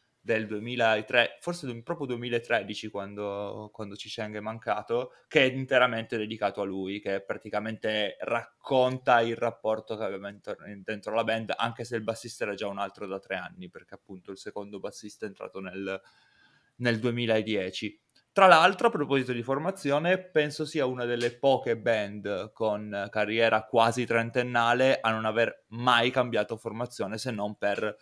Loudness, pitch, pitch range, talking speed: -28 LUFS, 115 Hz, 105-125 Hz, 160 wpm